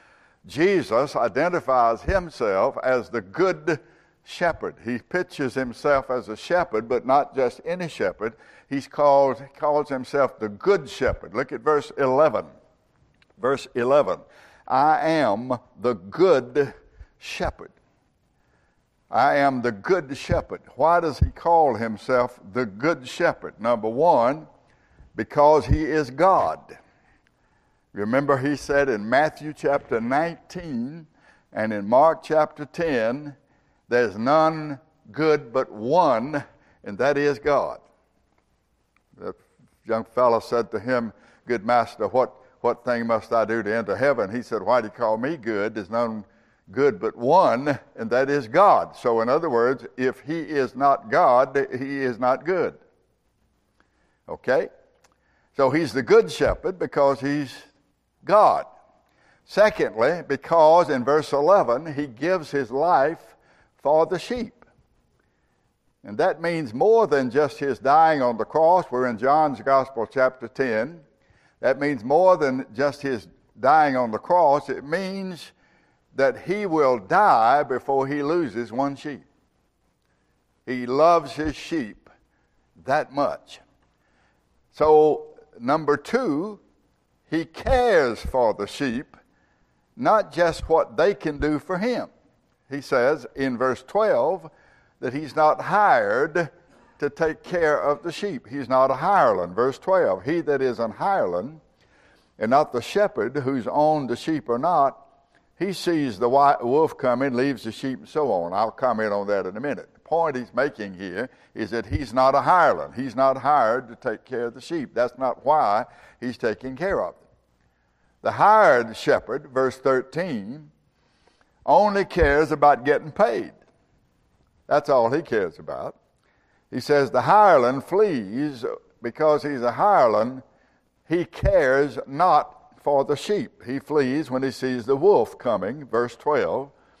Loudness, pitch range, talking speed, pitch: -22 LUFS, 125-165 Hz, 145 wpm, 140 Hz